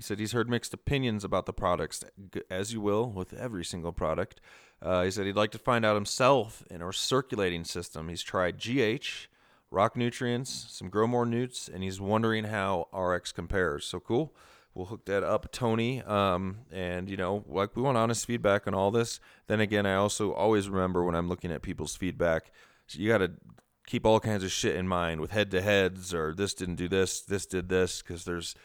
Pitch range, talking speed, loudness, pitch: 90-110 Hz, 210 wpm, -30 LUFS, 100 Hz